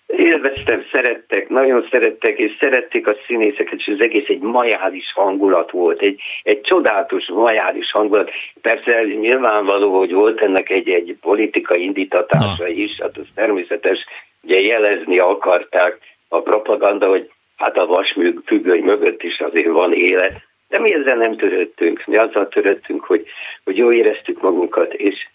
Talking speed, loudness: 145 wpm, -16 LUFS